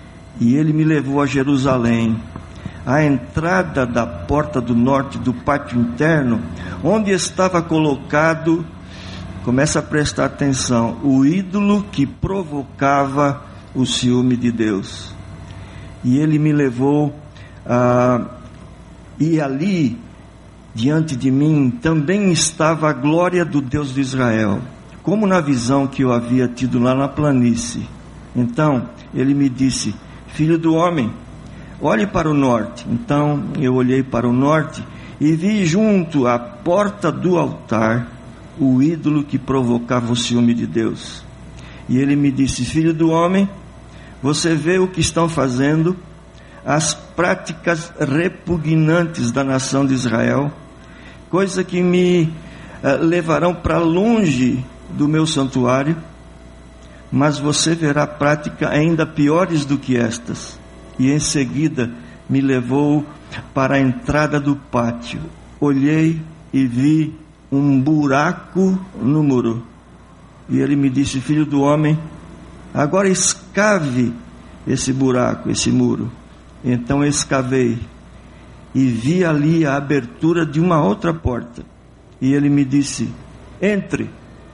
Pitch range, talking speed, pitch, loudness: 120-155 Hz, 125 wpm, 140 Hz, -17 LUFS